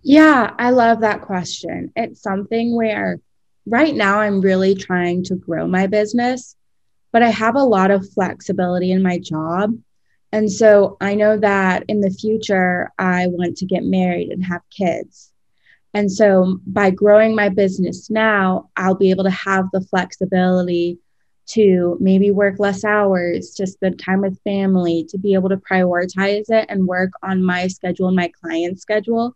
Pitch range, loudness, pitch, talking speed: 185-210 Hz, -17 LUFS, 195 Hz, 165 wpm